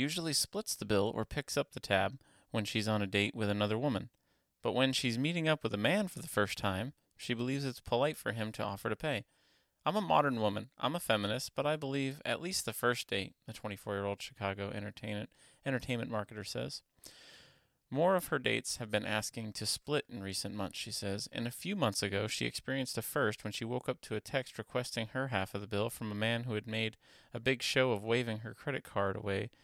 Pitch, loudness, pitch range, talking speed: 115 Hz, -35 LUFS, 105-135 Hz, 225 wpm